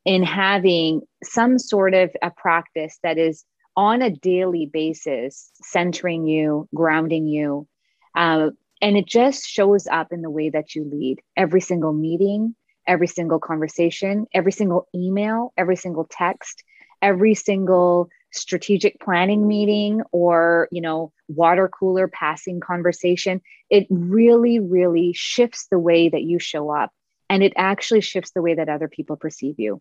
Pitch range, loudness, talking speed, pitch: 160-200 Hz, -20 LUFS, 150 wpm, 180 Hz